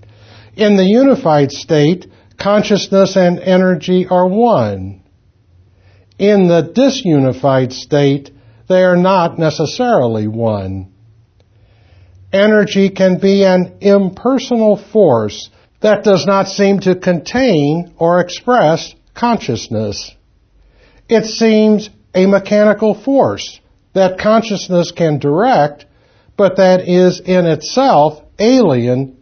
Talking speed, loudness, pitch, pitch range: 100 wpm, -12 LUFS, 175 Hz, 120-200 Hz